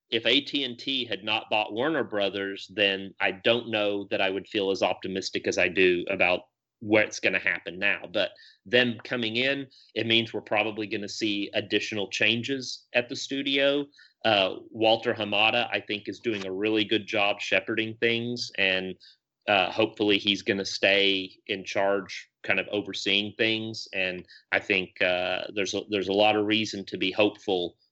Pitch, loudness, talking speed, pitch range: 110 Hz, -26 LUFS, 170 wpm, 100-120 Hz